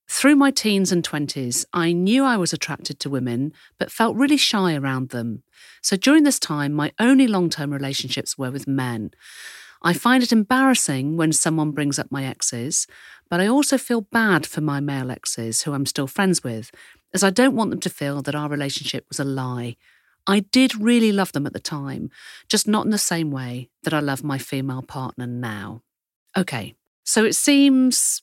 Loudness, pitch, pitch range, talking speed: -21 LUFS, 150 Hz, 135-215 Hz, 195 wpm